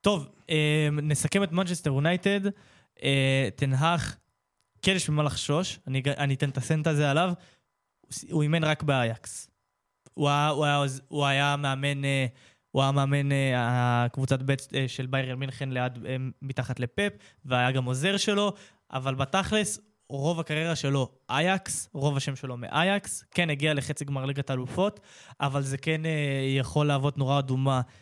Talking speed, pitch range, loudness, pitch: 130 wpm, 135-155 Hz, -27 LUFS, 140 Hz